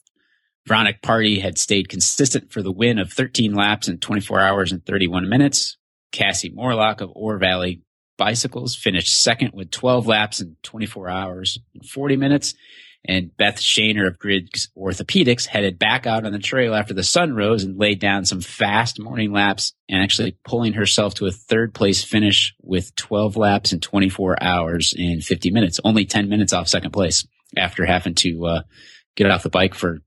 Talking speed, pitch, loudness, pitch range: 180 wpm, 100 Hz, -19 LUFS, 95-110 Hz